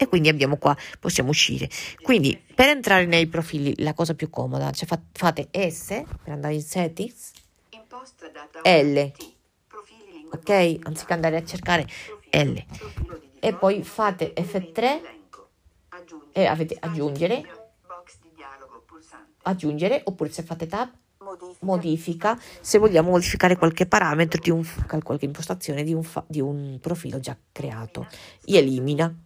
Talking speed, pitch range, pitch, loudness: 125 wpm, 150-190 Hz, 165 Hz, -23 LUFS